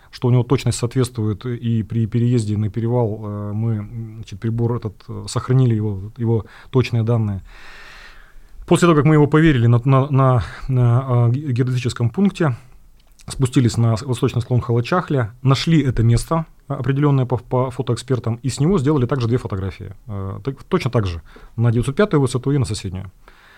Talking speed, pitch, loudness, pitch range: 150 wpm, 120 Hz, -19 LUFS, 115-135 Hz